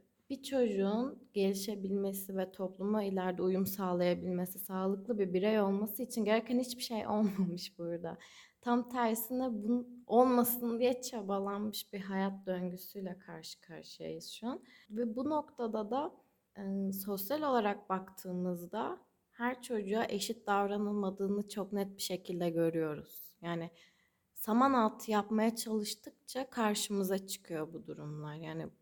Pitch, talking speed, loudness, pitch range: 205 Hz, 120 wpm, -36 LUFS, 185-235 Hz